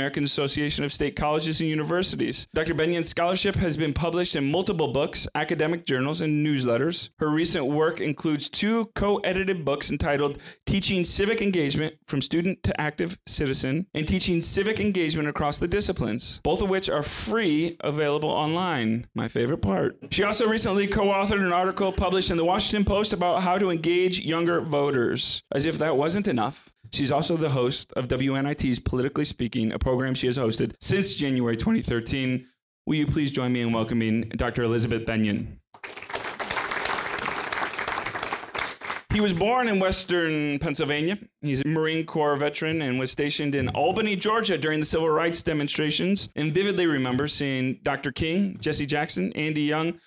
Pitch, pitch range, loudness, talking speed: 155 Hz, 140-180 Hz, -25 LUFS, 160 wpm